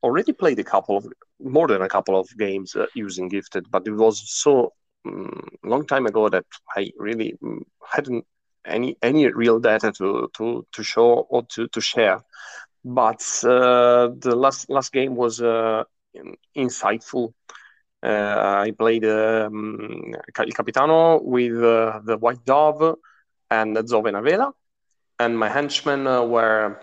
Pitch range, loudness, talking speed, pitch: 110-130 Hz, -21 LUFS, 145 wpm, 120 Hz